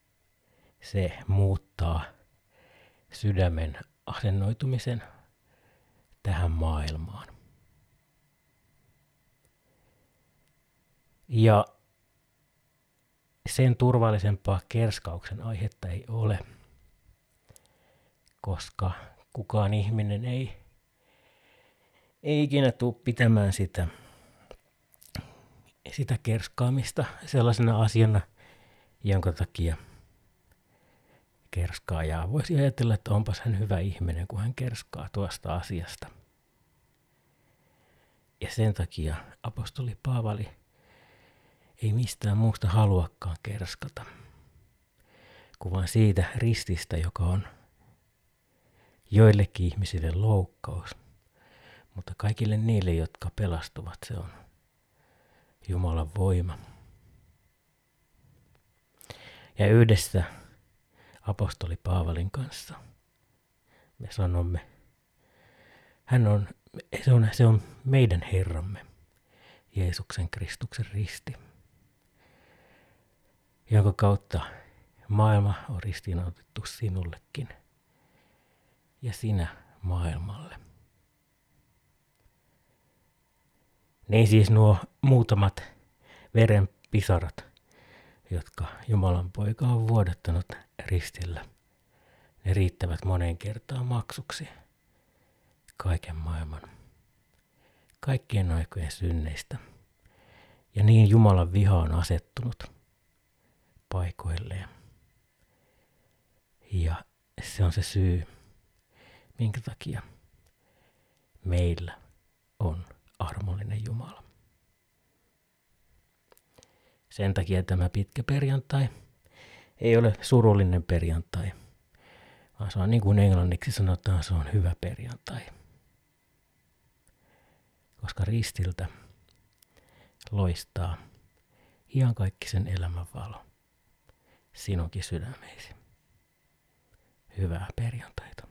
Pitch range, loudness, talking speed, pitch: 90-115 Hz, -28 LUFS, 75 wpm, 100 Hz